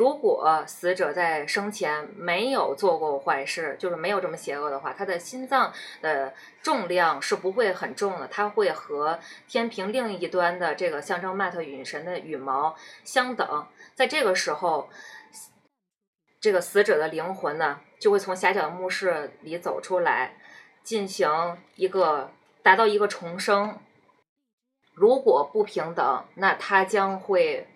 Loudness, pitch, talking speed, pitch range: -25 LUFS, 200 Hz, 220 characters per minute, 180-260 Hz